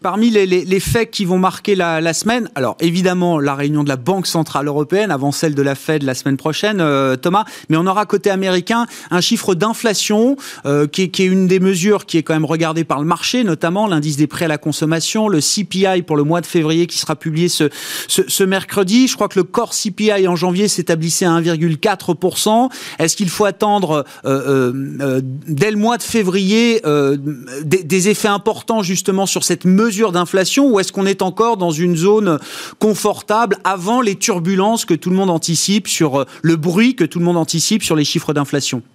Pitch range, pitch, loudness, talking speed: 160-205 Hz, 180 Hz, -15 LUFS, 210 wpm